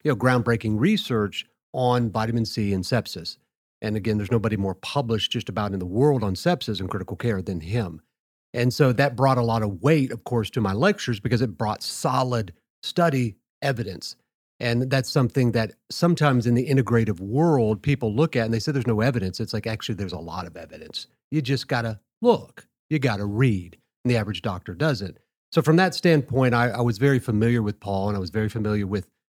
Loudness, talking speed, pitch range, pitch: -24 LUFS, 210 wpm, 105-135 Hz, 120 Hz